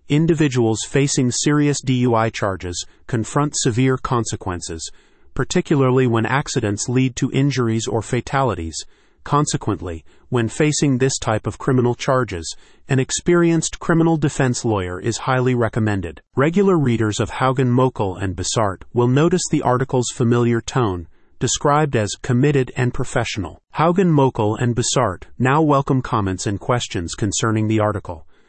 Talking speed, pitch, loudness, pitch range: 130 wpm, 125 Hz, -19 LUFS, 110-140 Hz